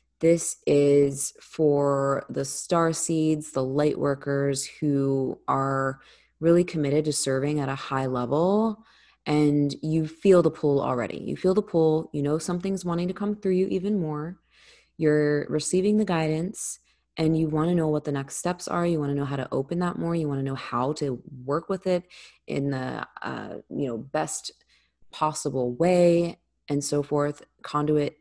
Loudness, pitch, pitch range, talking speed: -25 LUFS, 150 Hz, 140-170 Hz, 175 wpm